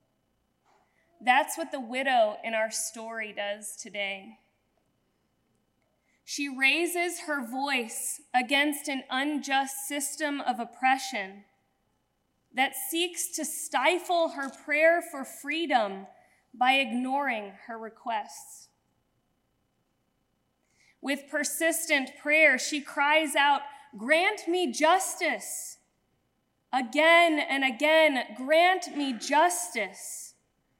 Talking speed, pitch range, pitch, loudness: 90 wpm, 250-315 Hz, 280 Hz, -27 LUFS